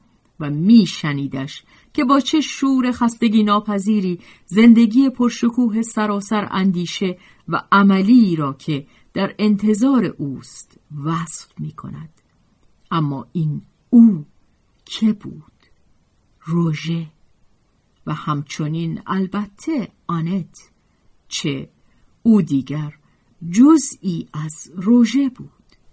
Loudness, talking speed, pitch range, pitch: -18 LUFS, 90 wpm, 155-230 Hz, 195 Hz